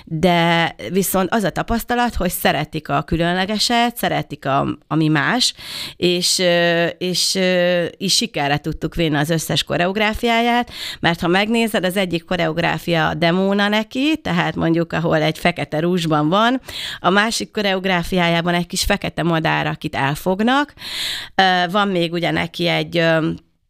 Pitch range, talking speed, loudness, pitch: 165-200 Hz, 135 wpm, -18 LUFS, 175 Hz